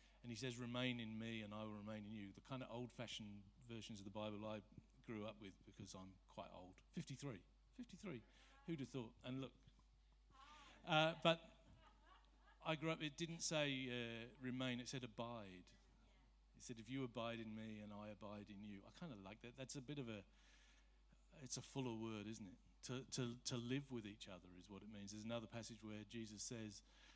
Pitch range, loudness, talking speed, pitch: 105-130 Hz, -50 LUFS, 205 wpm, 115 Hz